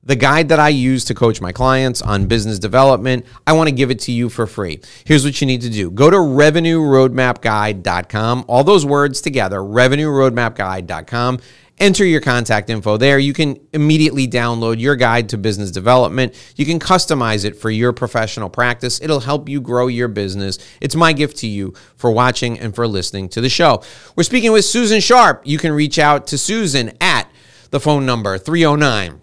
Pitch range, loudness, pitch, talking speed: 115-150 Hz, -14 LUFS, 125 Hz, 190 wpm